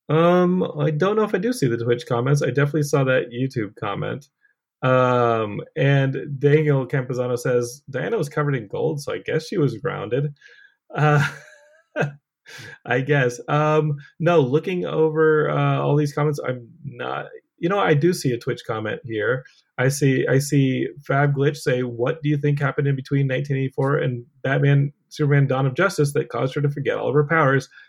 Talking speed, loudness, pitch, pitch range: 185 wpm, -21 LUFS, 145 Hz, 130-155 Hz